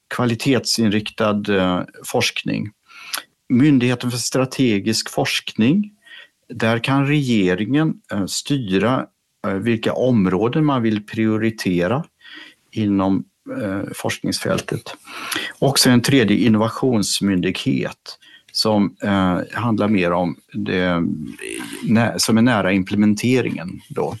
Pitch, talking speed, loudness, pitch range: 110 Hz, 75 wpm, -19 LUFS, 95-125 Hz